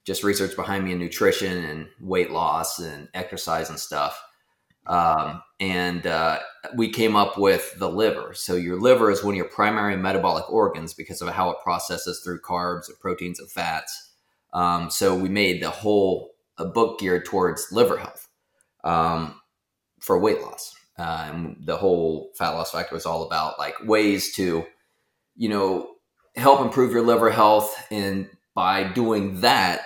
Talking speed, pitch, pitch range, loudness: 165 wpm, 95 Hz, 90-105 Hz, -23 LUFS